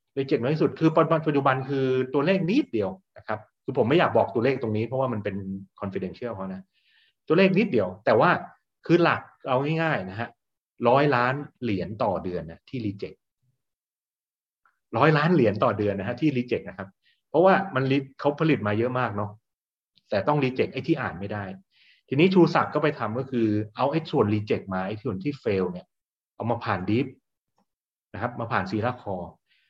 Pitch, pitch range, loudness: 125 Hz, 105-145 Hz, -25 LUFS